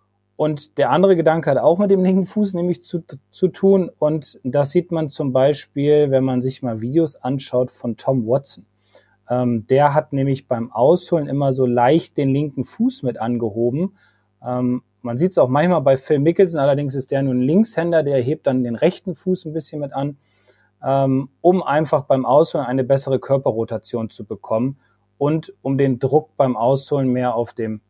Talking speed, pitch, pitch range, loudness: 185 wpm, 135 Hz, 125-160 Hz, -19 LUFS